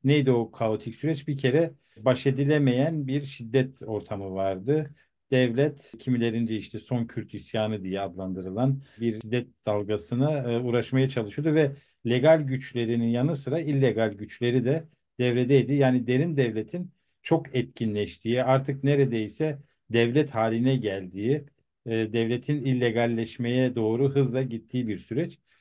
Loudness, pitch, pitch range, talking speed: -26 LUFS, 125 Hz, 115-140 Hz, 120 wpm